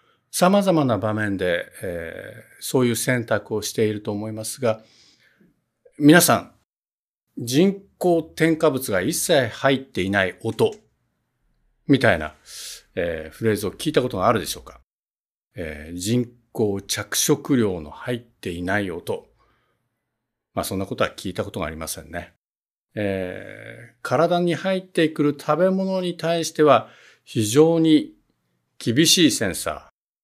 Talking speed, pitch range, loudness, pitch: 260 characters per minute, 100-155 Hz, -21 LUFS, 115 Hz